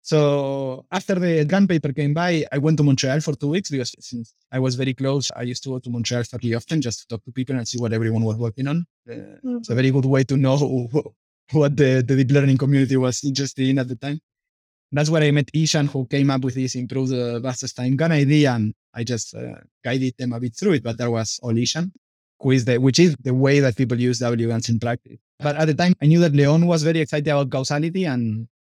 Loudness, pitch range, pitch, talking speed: -21 LUFS, 125-150 Hz, 135 Hz, 245 wpm